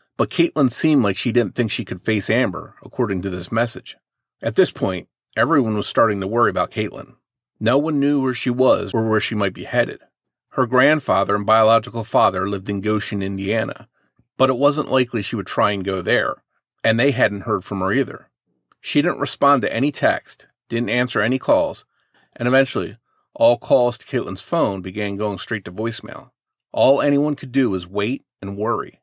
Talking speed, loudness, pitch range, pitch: 190 wpm, -20 LUFS, 100-130 Hz, 115 Hz